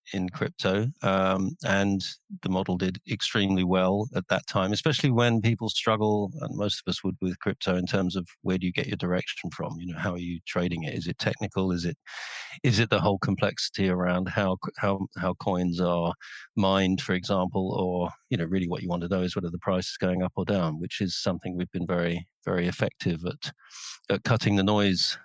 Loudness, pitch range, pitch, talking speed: -27 LUFS, 90-100 Hz, 95 Hz, 215 wpm